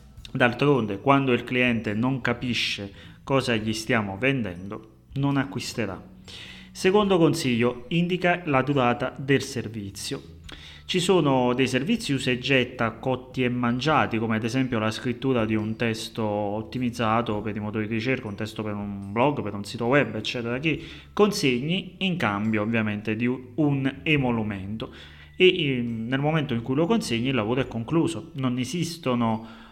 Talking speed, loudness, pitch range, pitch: 150 wpm, -25 LUFS, 110-135 Hz, 120 Hz